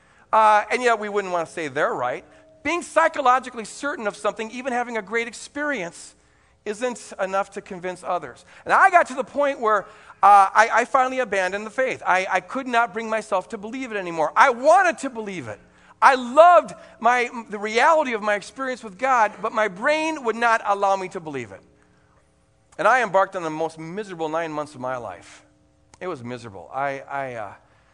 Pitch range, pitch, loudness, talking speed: 185-255 Hz, 215 Hz, -21 LUFS, 200 wpm